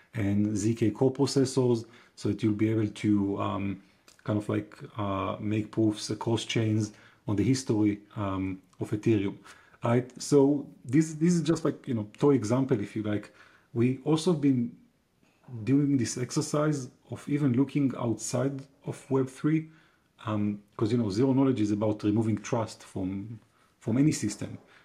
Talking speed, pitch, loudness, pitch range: 160 wpm, 115 Hz, -28 LUFS, 105-135 Hz